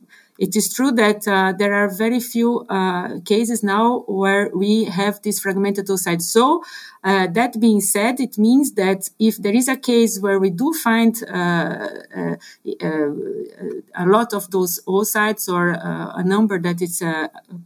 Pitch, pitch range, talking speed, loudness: 205 Hz, 190-230 Hz, 175 wpm, -19 LUFS